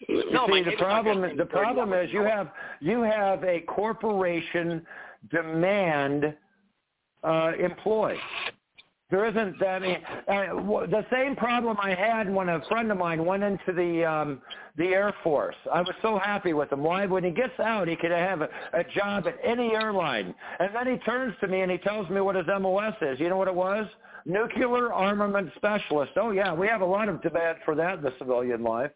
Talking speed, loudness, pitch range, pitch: 195 wpm, -27 LUFS, 170-210 Hz, 190 Hz